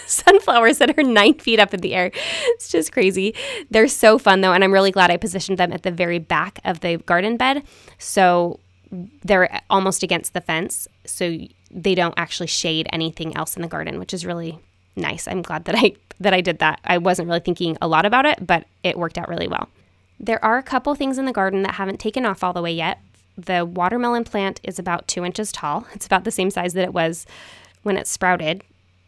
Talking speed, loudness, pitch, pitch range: 225 wpm, -19 LUFS, 185 Hz, 170-210 Hz